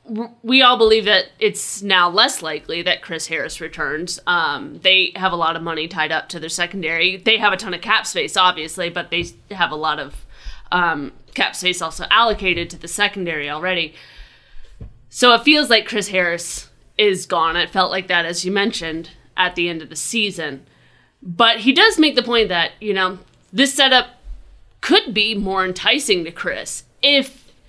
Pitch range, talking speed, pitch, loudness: 170-225 Hz, 185 wpm, 185 Hz, -17 LUFS